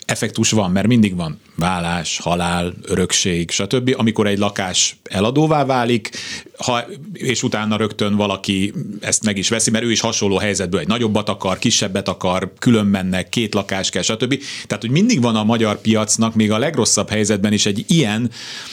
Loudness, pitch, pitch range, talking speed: -17 LUFS, 110 Hz, 100-120 Hz, 170 wpm